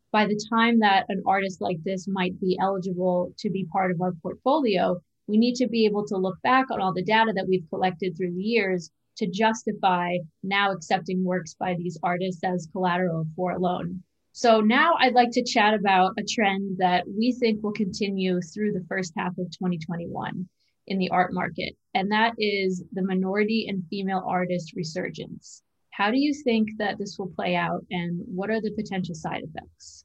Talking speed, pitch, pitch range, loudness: 195 wpm, 190 Hz, 180-210 Hz, -25 LUFS